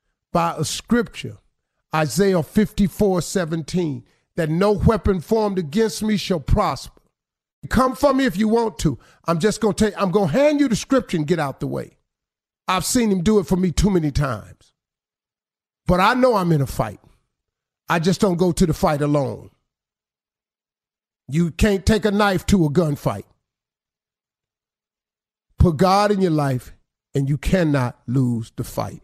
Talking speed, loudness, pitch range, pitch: 165 wpm, -20 LUFS, 150-205 Hz, 180 Hz